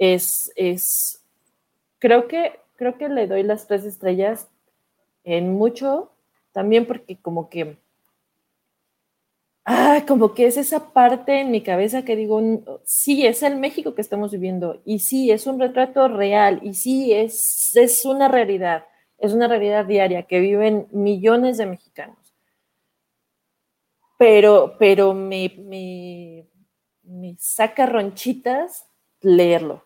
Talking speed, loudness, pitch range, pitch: 130 wpm, -18 LUFS, 190-250 Hz, 215 Hz